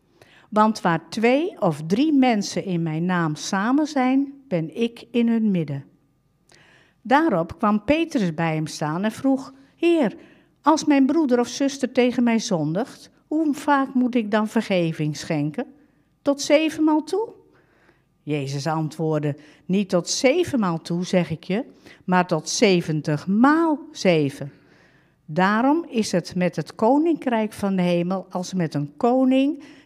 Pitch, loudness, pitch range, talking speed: 210 Hz, -22 LUFS, 165-270 Hz, 140 wpm